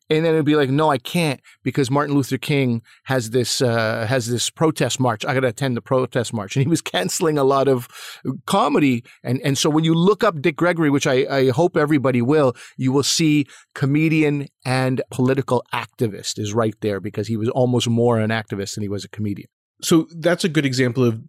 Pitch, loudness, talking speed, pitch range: 135 Hz, -20 LUFS, 215 wpm, 120-150 Hz